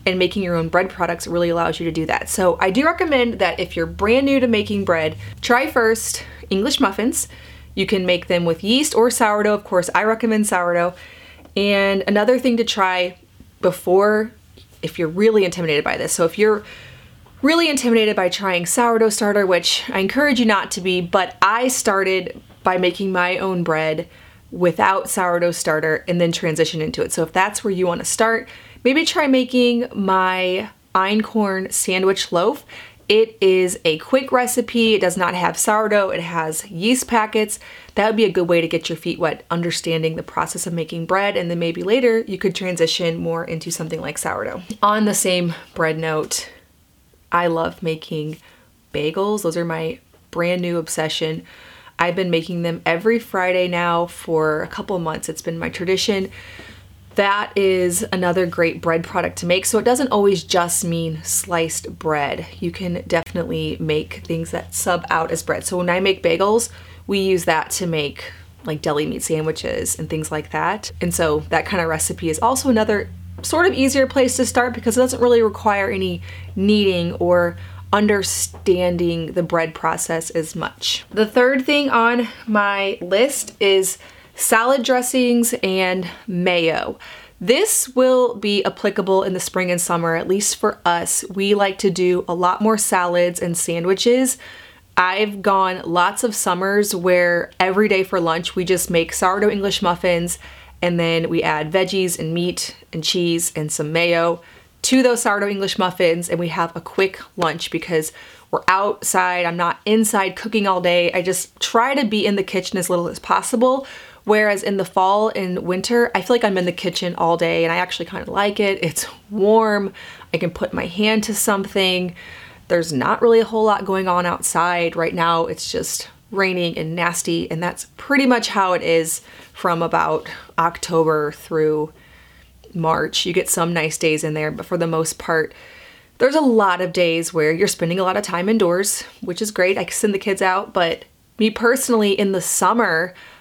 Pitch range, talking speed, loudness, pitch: 170-210 Hz, 185 wpm, -19 LUFS, 185 Hz